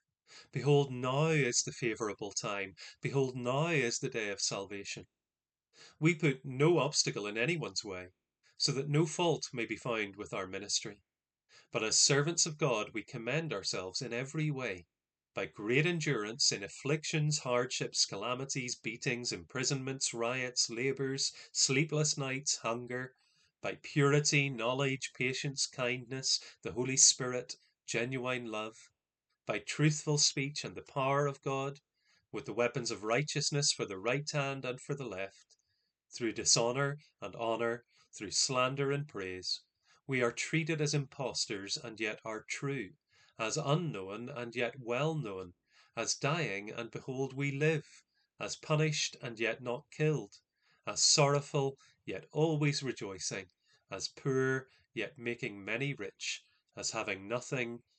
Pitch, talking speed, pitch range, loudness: 135 Hz, 140 wpm, 120-145 Hz, -33 LUFS